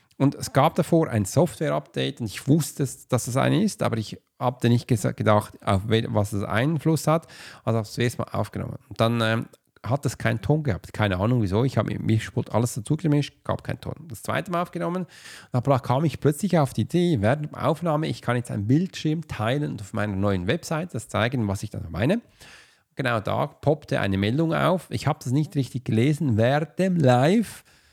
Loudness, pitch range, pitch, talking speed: -24 LUFS, 110-150 Hz, 125 Hz, 210 wpm